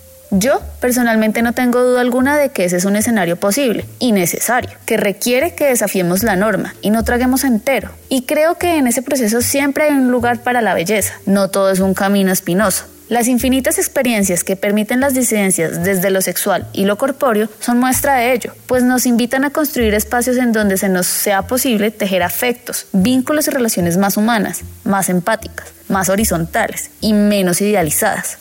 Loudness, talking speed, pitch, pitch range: -15 LUFS, 185 wpm, 225 Hz, 195-255 Hz